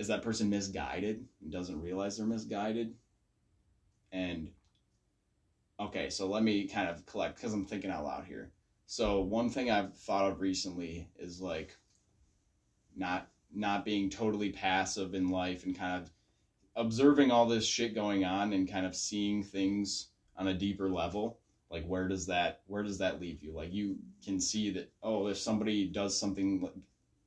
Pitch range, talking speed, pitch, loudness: 95-105 Hz, 170 wpm, 100 Hz, -34 LUFS